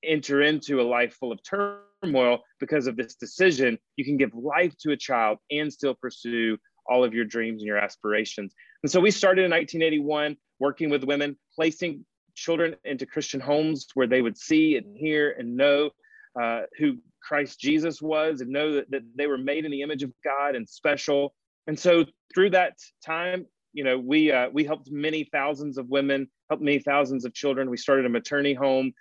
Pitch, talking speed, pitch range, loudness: 145 Hz, 195 wpm, 130-160 Hz, -25 LUFS